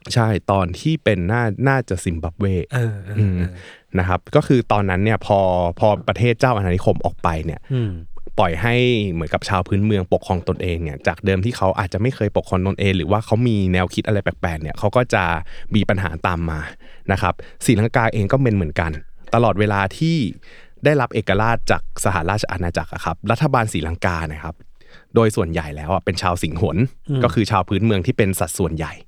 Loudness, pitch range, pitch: -20 LUFS, 90-115 Hz, 100 Hz